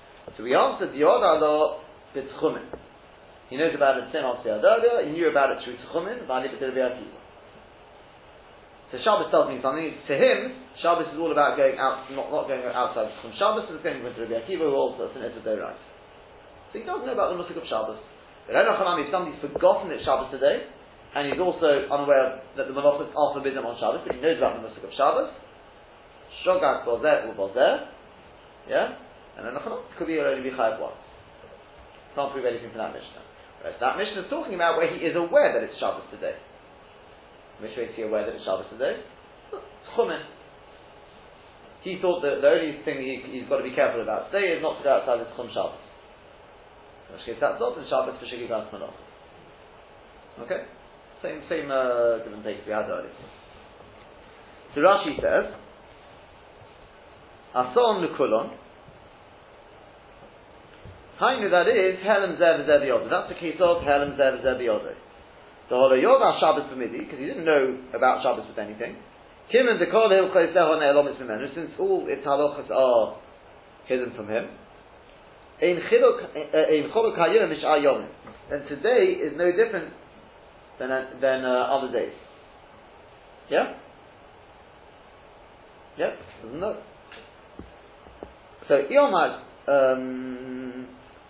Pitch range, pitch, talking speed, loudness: 130-185 Hz, 145 Hz, 155 wpm, -24 LUFS